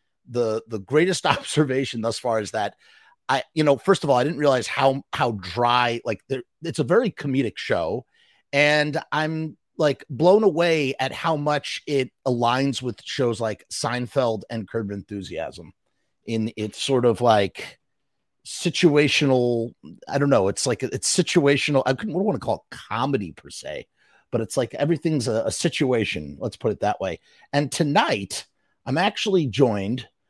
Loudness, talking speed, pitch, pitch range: -23 LUFS, 165 wpm, 135 Hz, 120-155 Hz